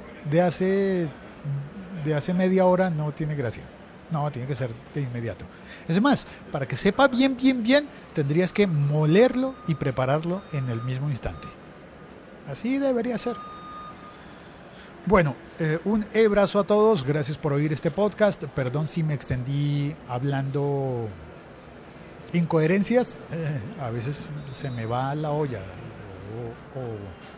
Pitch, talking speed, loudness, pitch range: 150 Hz, 130 wpm, -25 LUFS, 135-195 Hz